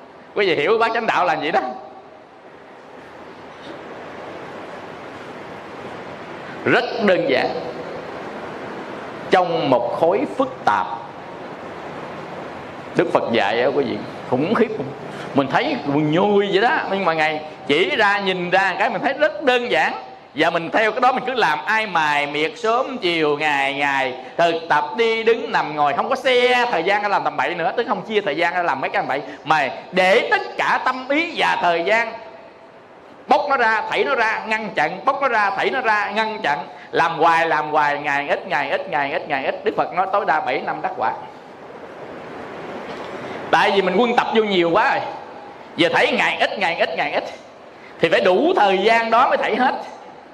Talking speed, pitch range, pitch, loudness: 190 wpm, 165-235 Hz, 205 Hz, -19 LUFS